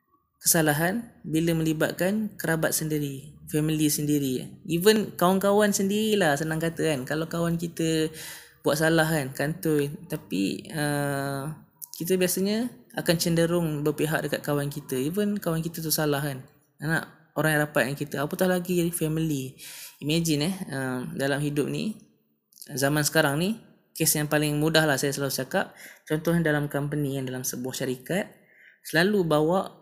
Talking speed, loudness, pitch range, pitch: 140 wpm, -26 LUFS, 145-170 Hz, 155 Hz